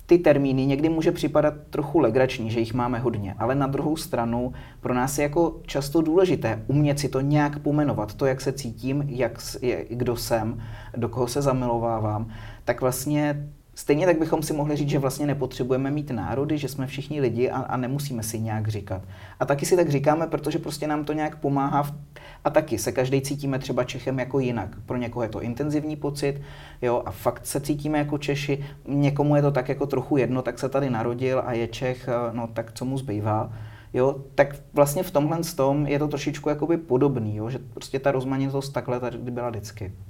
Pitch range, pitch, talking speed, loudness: 120-145 Hz, 135 Hz, 200 wpm, -25 LUFS